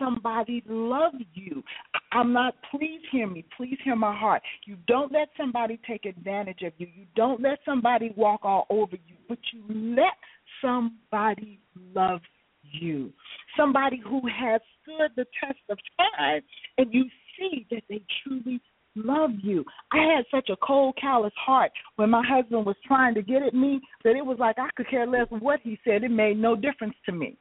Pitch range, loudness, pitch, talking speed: 215-270 Hz, -26 LUFS, 240 Hz, 180 wpm